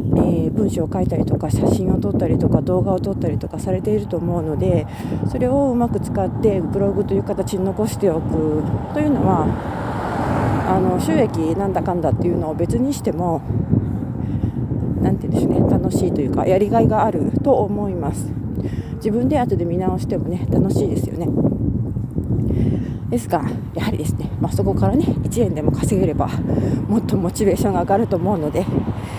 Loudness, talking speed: -19 LUFS, 340 characters per minute